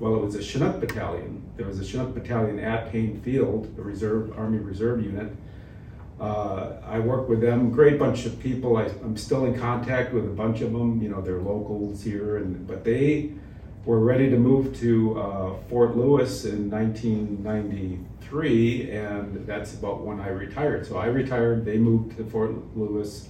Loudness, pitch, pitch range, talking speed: -25 LUFS, 110 Hz, 105-120 Hz, 185 wpm